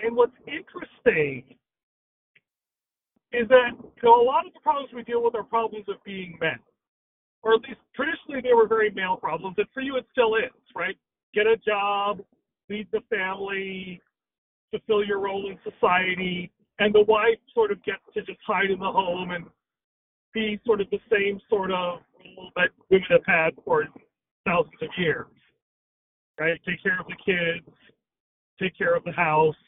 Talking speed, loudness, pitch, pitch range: 175 wpm, -24 LUFS, 210 Hz, 185-260 Hz